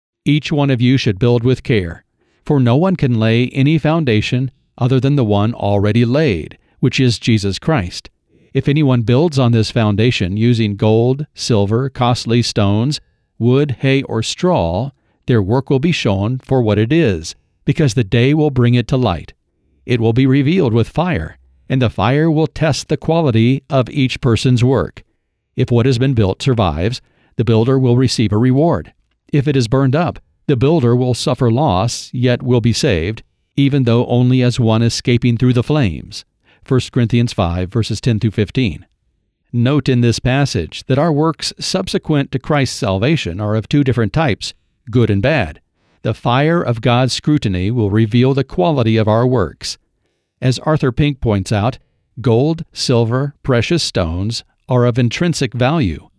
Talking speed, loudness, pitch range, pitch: 170 wpm, -15 LUFS, 110-140 Hz, 125 Hz